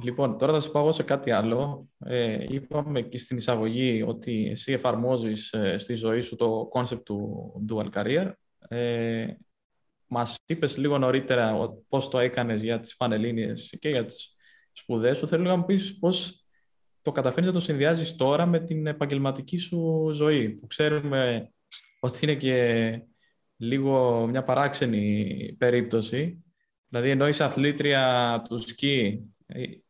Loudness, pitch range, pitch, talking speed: -26 LUFS, 115-150 Hz, 125 Hz, 145 wpm